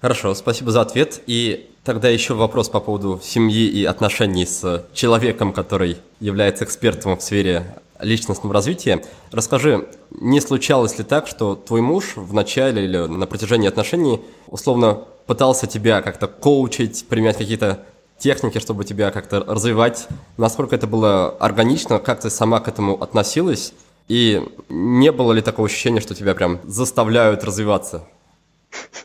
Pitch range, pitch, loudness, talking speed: 100-120 Hz, 110 Hz, -18 LUFS, 145 wpm